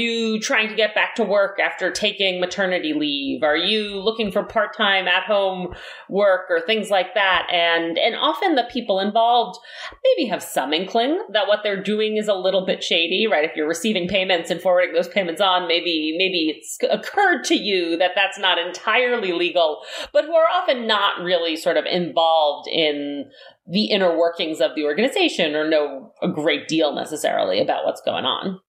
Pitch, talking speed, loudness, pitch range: 195 Hz, 190 wpm, -20 LUFS, 175-220 Hz